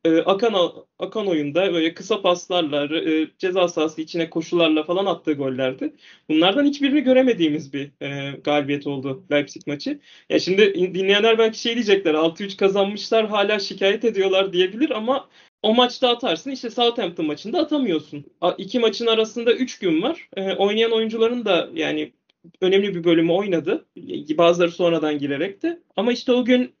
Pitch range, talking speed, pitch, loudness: 165-235 Hz, 150 wpm, 190 Hz, -21 LUFS